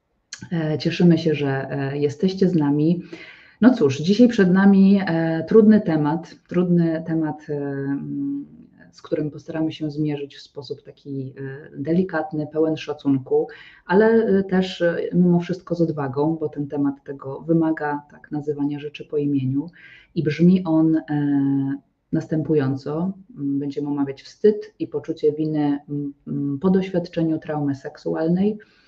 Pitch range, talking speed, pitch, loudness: 145-175 Hz, 115 wpm, 155 Hz, -21 LUFS